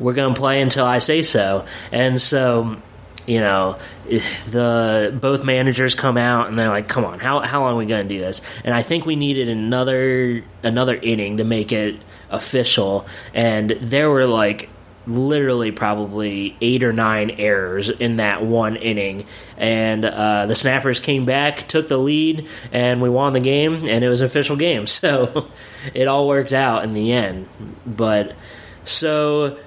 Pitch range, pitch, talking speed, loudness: 105-130 Hz, 120 Hz, 175 wpm, -18 LUFS